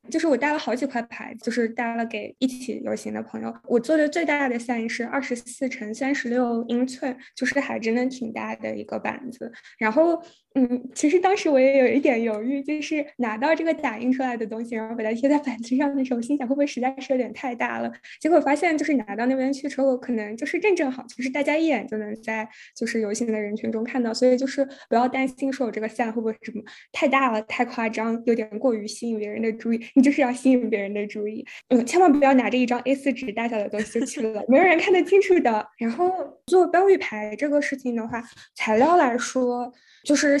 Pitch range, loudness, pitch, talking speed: 225-280 Hz, -23 LUFS, 250 Hz, 345 characters per minute